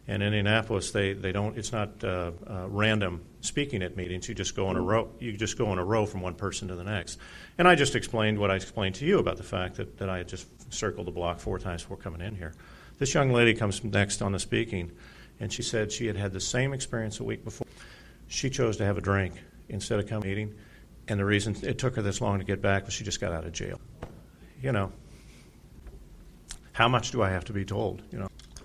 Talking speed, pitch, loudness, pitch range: 245 wpm, 100 Hz, -29 LUFS, 95-115 Hz